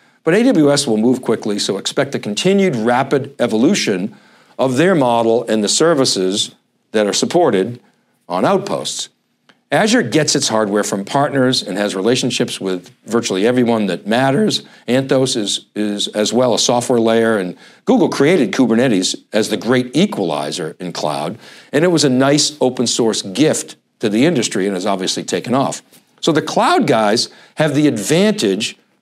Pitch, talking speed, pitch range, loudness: 125 Hz, 160 wpm, 110-145 Hz, -16 LUFS